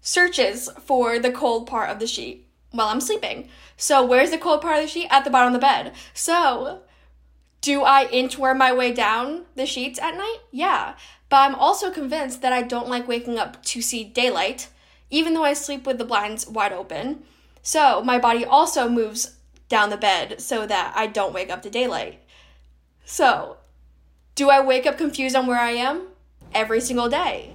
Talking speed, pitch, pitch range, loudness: 195 wpm, 255 Hz, 225-280 Hz, -21 LUFS